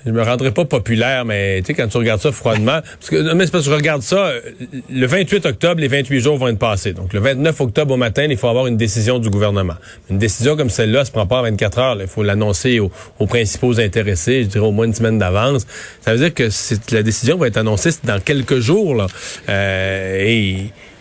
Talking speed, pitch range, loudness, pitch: 250 wpm, 105-135 Hz, -16 LUFS, 115 Hz